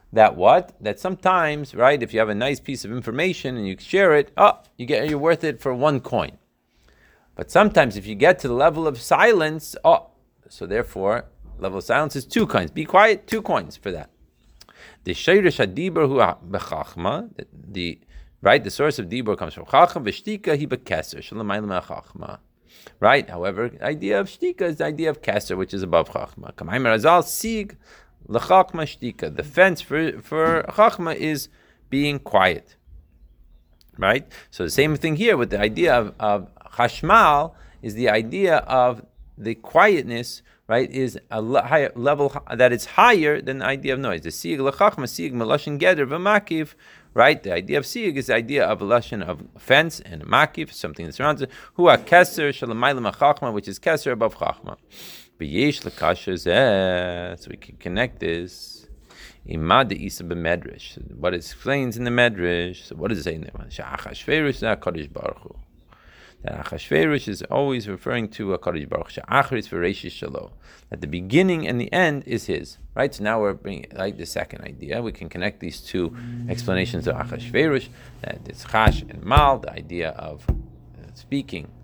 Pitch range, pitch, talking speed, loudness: 100-155 Hz, 130 Hz, 155 wpm, -21 LUFS